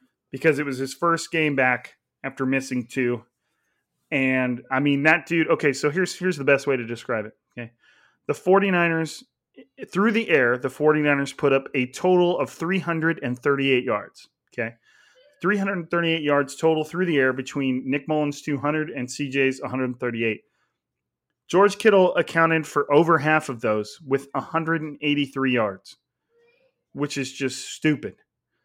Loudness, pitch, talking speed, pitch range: -23 LUFS, 145 Hz, 145 wpm, 130-165 Hz